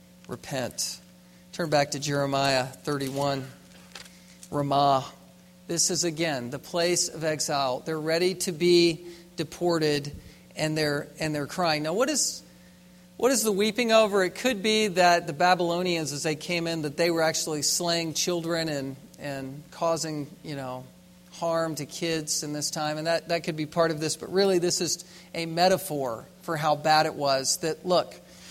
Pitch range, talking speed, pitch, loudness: 145-175 Hz, 170 wpm, 160 Hz, -26 LUFS